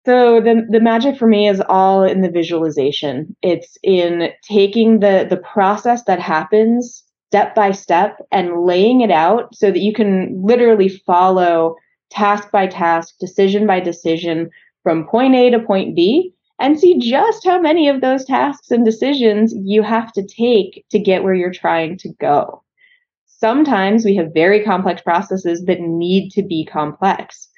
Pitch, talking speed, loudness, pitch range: 200 Hz, 165 wpm, -14 LUFS, 180-235 Hz